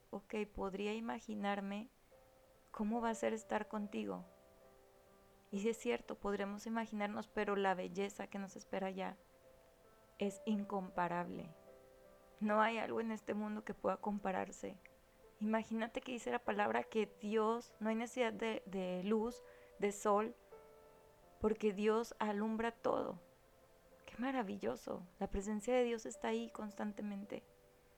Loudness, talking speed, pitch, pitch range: -41 LUFS, 130 wpm, 210 Hz, 190-225 Hz